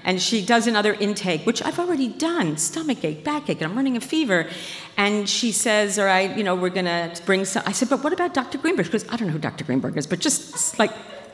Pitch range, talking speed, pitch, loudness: 180-250 Hz, 245 wpm, 205 Hz, -22 LUFS